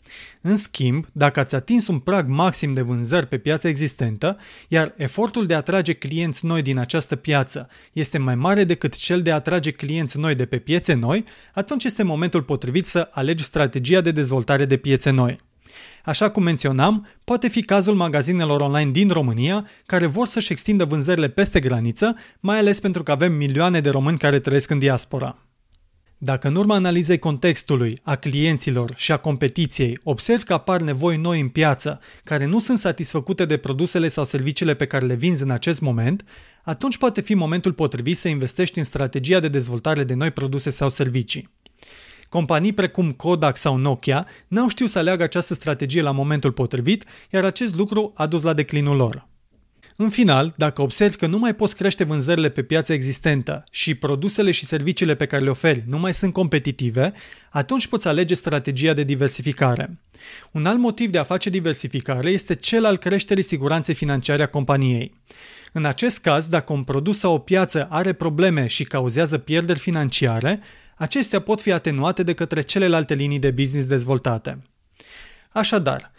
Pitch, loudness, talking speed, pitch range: 155 Hz, -21 LUFS, 175 wpm, 140-185 Hz